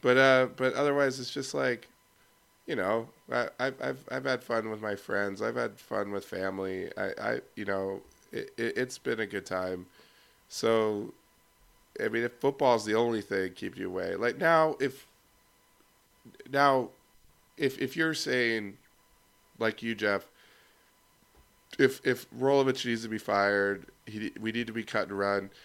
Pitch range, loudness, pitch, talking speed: 100-130 Hz, -30 LUFS, 115 Hz, 165 wpm